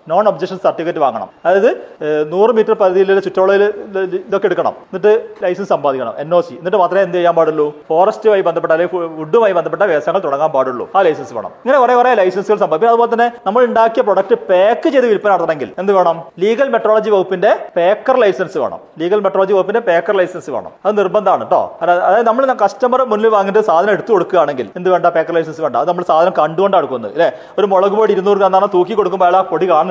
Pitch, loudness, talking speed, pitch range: 195 Hz, -13 LUFS, 170 wpm, 175-215 Hz